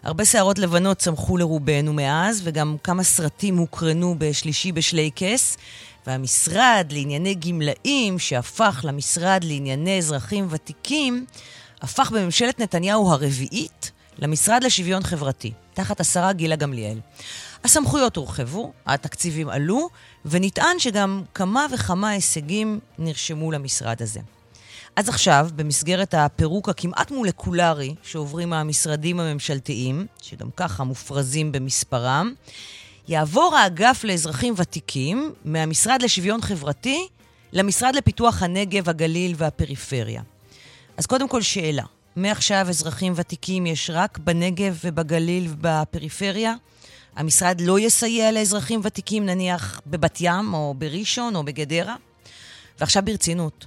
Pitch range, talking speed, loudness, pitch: 145-195 Hz, 105 wpm, -21 LUFS, 170 Hz